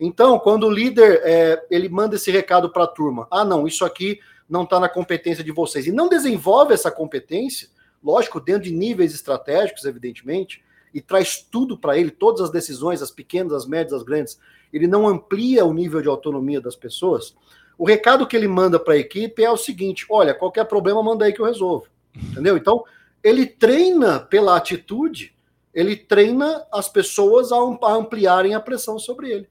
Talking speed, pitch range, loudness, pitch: 185 wpm, 170-240 Hz, -18 LUFS, 200 Hz